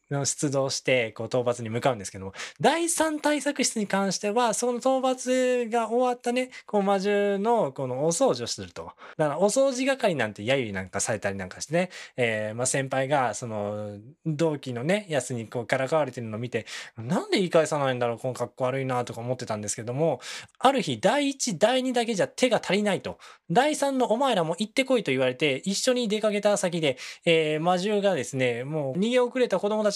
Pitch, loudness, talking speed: 165 Hz, -26 LUFS, 400 characters per minute